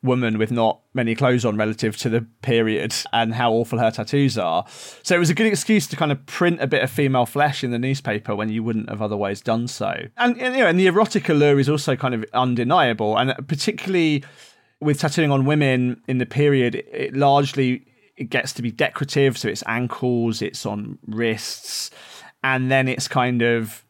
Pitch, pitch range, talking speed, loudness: 125 Hz, 115-145 Hz, 205 wpm, -21 LUFS